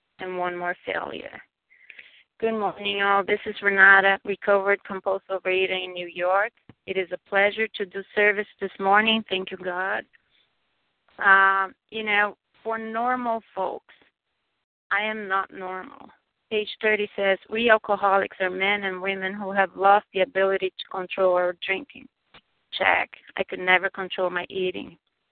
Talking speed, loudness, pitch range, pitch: 150 wpm, -23 LUFS, 190-205 Hz, 195 Hz